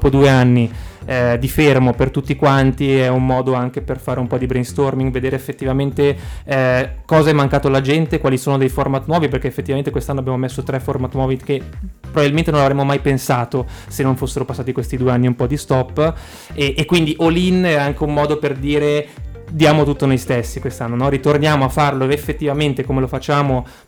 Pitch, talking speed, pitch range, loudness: 135 Hz, 200 wpm, 130-145 Hz, -17 LUFS